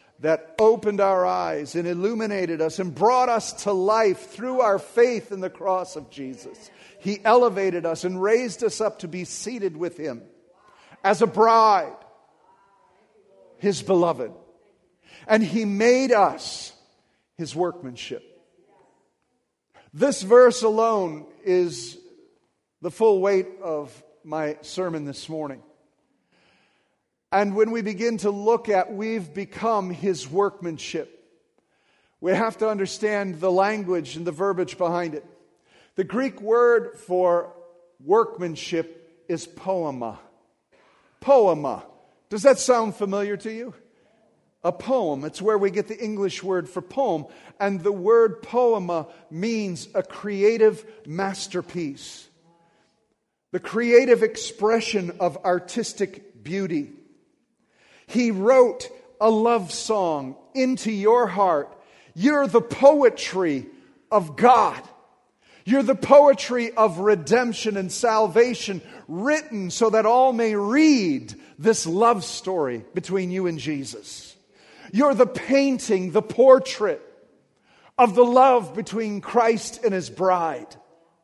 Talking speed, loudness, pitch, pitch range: 120 wpm, -22 LUFS, 205 Hz, 175-230 Hz